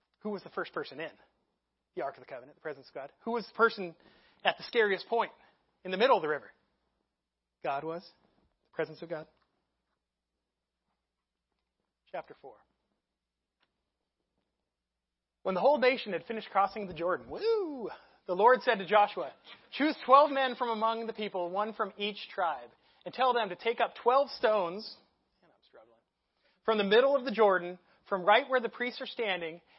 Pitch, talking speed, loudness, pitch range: 210 Hz, 170 wpm, -30 LUFS, 170-240 Hz